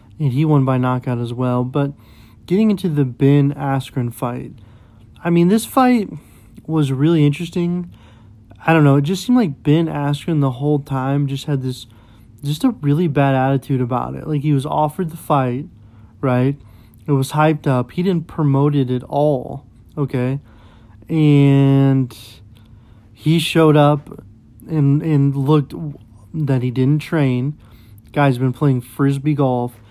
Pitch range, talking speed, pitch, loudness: 120-150 Hz, 155 wpm, 140 Hz, -17 LUFS